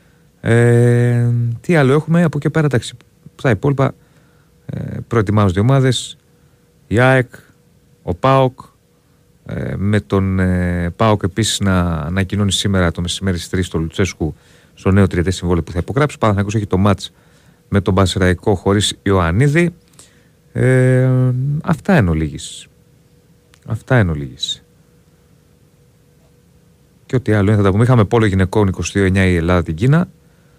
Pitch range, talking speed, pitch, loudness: 95-130 Hz, 145 wpm, 110 Hz, -16 LUFS